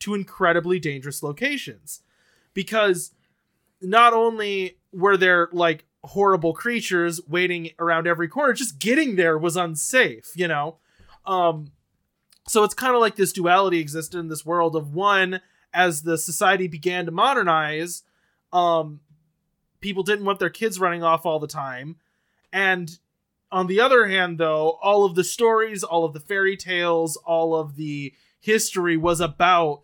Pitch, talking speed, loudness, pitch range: 175 Hz, 150 wpm, -21 LUFS, 165-195 Hz